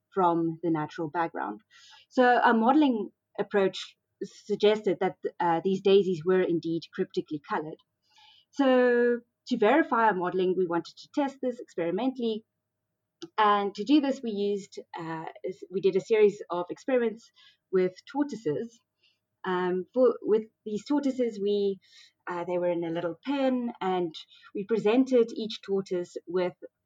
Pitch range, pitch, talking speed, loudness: 180-250 Hz, 205 Hz, 135 wpm, -28 LUFS